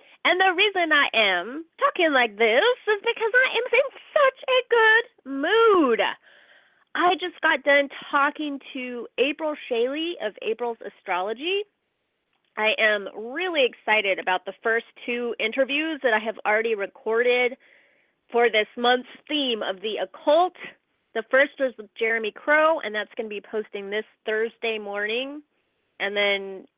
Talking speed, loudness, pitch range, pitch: 150 wpm, -23 LUFS, 220-325 Hz, 260 Hz